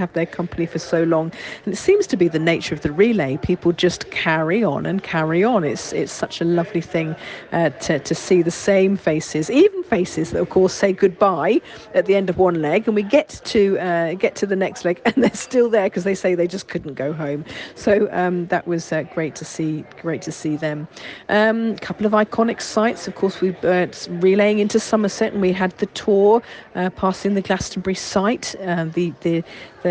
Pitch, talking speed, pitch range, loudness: 185 Hz, 225 wpm, 170-205 Hz, -20 LUFS